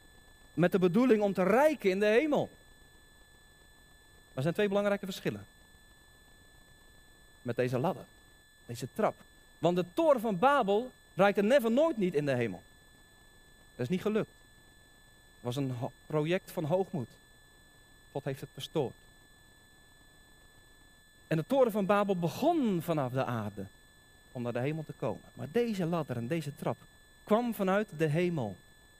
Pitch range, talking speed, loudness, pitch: 120-200 Hz, 150 wpm, -31 LUFS, 160 Hz